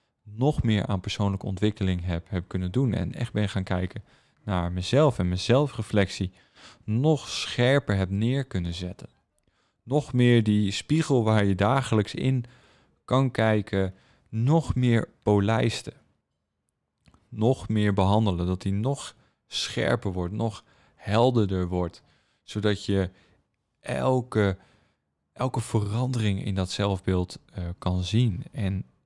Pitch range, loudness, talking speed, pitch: 95-120 Hz, -26 LUFS, 125 wpm, 105 Hz